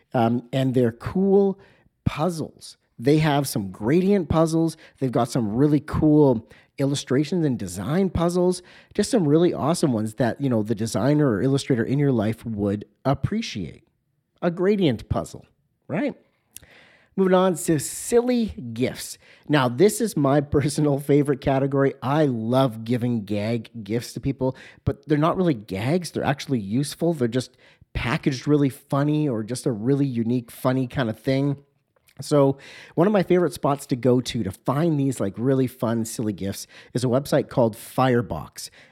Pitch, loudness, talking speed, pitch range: 135 Hz, -23 LUFS, 160 wpm, 120-155 Hz